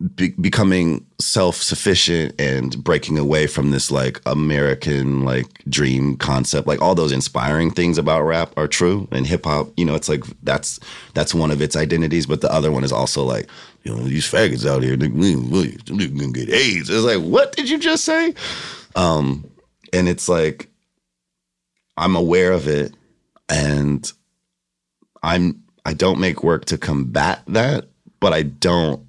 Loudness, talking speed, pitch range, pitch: -18 LUFS, 160 wpm, 70-85 Hz, 75 Hz